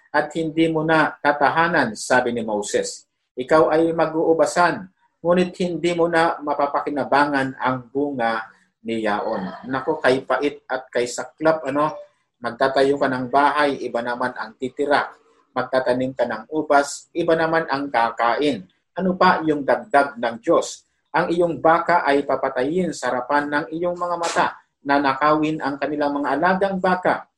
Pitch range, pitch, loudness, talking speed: 130-165 Hz, 145 Hz, -21 LUFS, 145 wpm